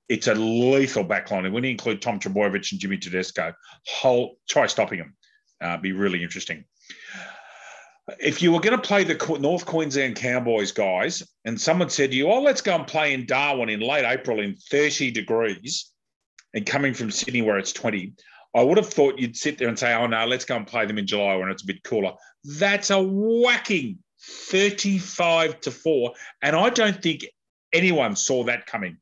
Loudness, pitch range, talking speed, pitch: -23 LUFS, 115-175 Hz, 195 wpm, 140 Hz